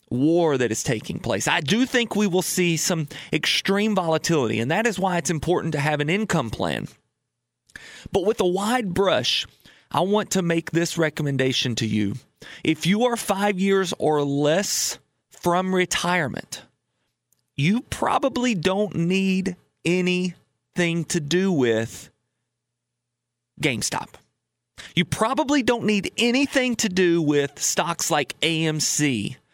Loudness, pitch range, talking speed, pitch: -22 LUFS, 145-195 Hz, 135 wpm, 175 Hz